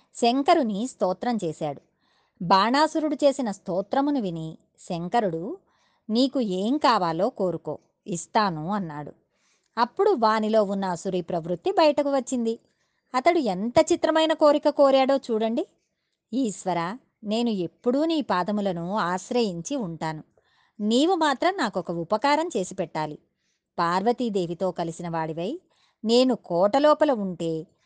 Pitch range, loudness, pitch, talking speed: 180-275 Hz, -24 LUFS, 220 Hz, 100 wpm